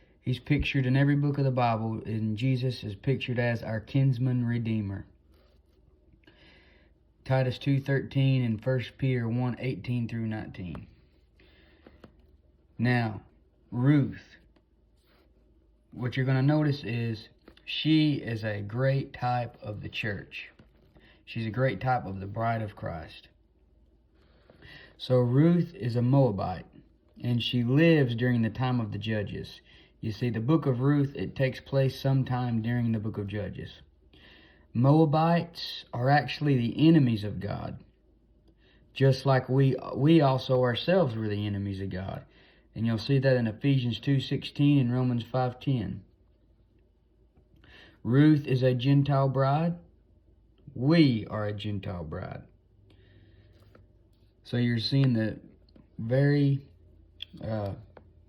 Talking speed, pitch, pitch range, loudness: 130 wpm, 115 Hz, 100-135 Hz, -27 LUFS